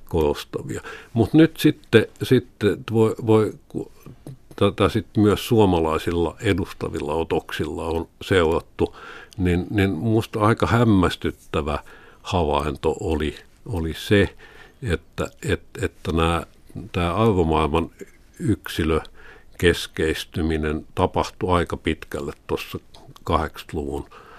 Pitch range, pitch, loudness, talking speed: 80-110 Hz, 95 Hz, -22 LUFS, 90 wpm